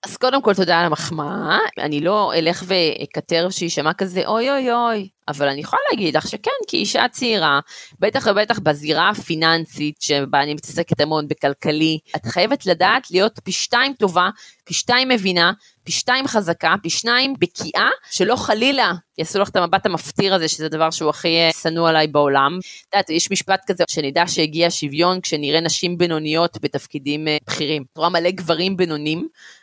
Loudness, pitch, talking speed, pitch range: -18 LUFS, 170 Hz, 165 wpm, 155-195 Hz